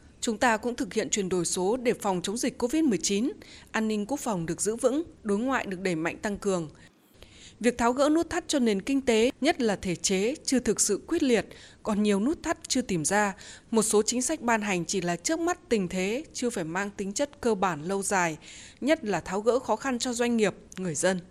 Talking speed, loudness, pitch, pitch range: 235 wpm, -27 LUFS, 220 Hz, 195-255 Hz